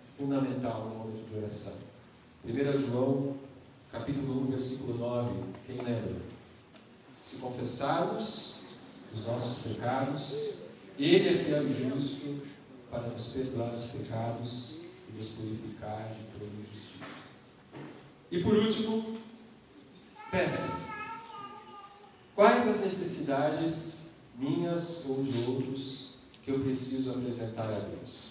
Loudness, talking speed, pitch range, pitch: -31 LUFS, 110 wpm, 115-145 Hz, 130 Hz